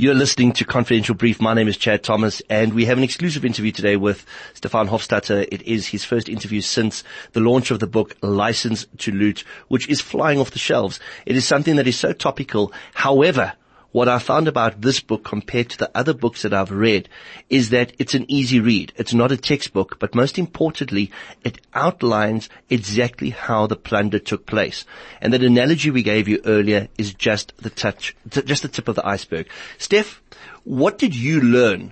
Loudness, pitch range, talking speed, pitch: -19 LUFS, 110-135 Hz, 195 wpm, 120 Hz